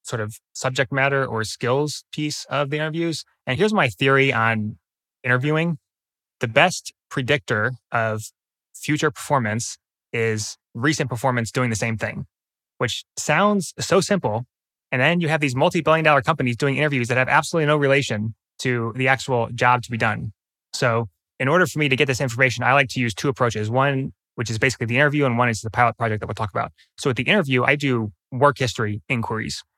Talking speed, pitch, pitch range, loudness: 195 wpm, 130 Hz, 115-145 Hz, -21 LUFS